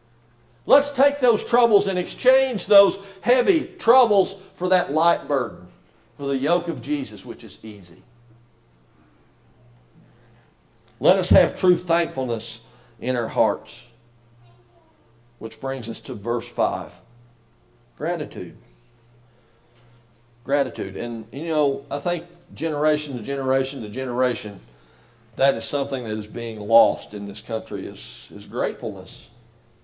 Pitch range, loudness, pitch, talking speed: 115-165 Hz, -22 LUFS, 120 Hz, 120 wpm